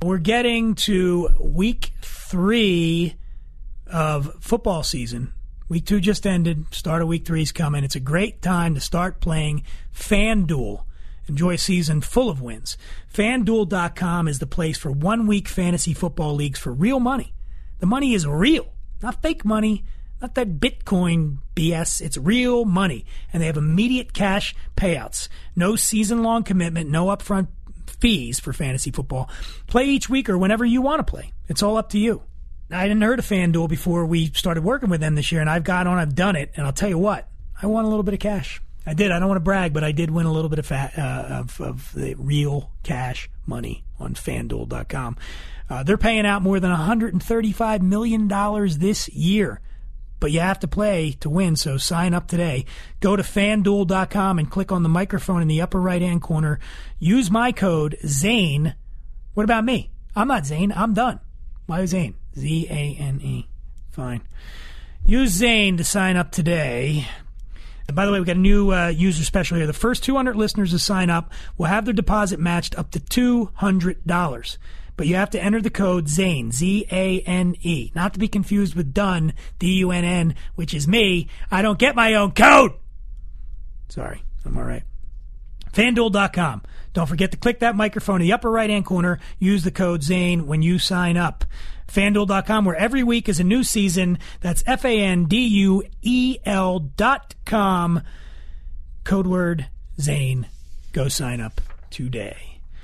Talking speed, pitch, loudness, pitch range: 185 wpm, 175 Hz, -21 LUFS, 150-205 Hz